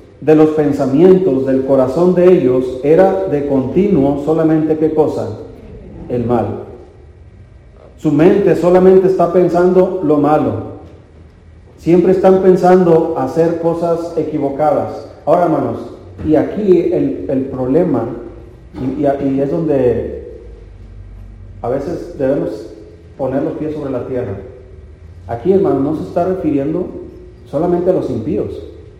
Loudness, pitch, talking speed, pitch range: -13 LUFS, 150 Hz, 120 wpm, 120-175 Hz